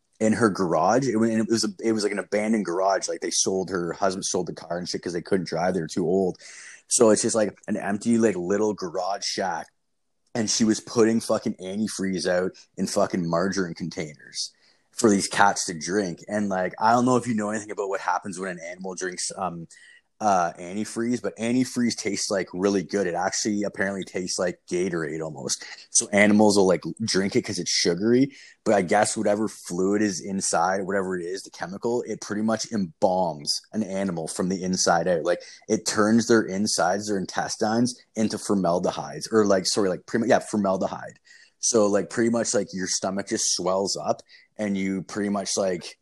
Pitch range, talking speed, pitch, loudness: 95-110 Hz, 200 wpm, 105 Hz, -24 LUFS